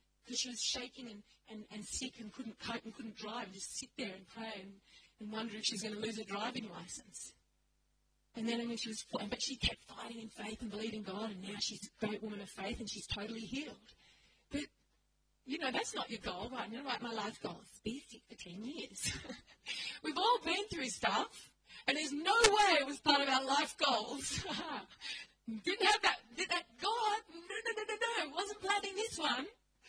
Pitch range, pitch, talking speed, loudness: 215-300 Hz, 235 Hz, 215 wpm, -38 LUFS